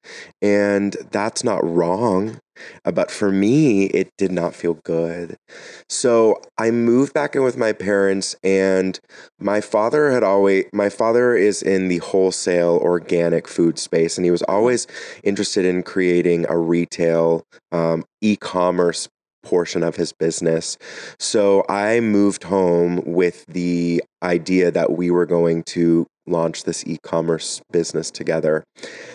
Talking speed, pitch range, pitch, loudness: 135 wpm, 85-100 Hz, 90 Hz, -19 LUFS